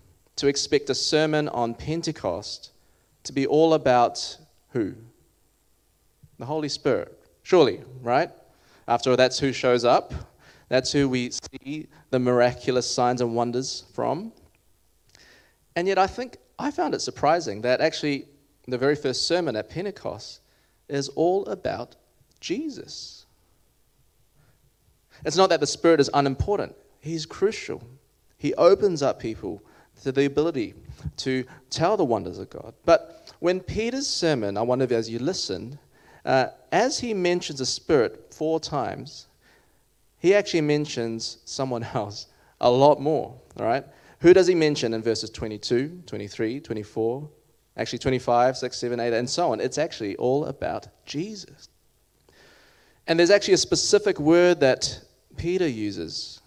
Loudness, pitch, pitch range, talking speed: -24 LUFS, 140 Hz, 125-170 Hz, 140 wpm